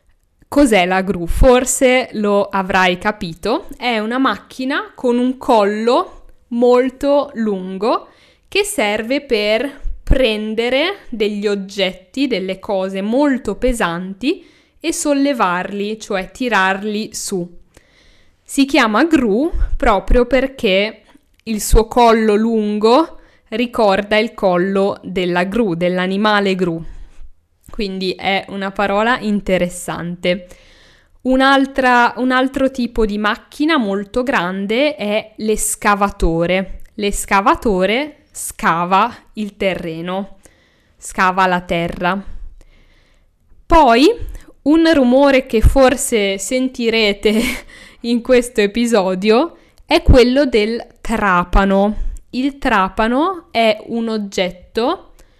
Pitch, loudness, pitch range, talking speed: 220 Hz, -16 LUFS, 195-255 Hz, 95 wpm